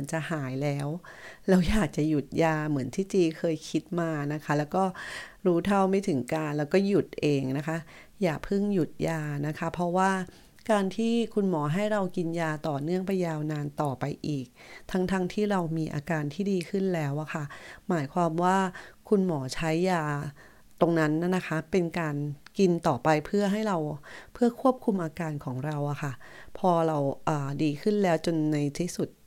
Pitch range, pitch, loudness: 150-185 Hz, 165 Hz, -28 LUFS